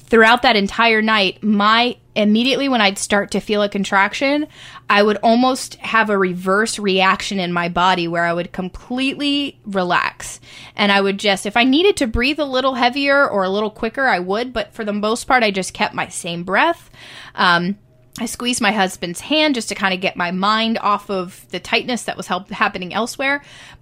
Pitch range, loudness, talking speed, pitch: 190-245 Hz, -17 LUFS, 200 wpm, 210 Hz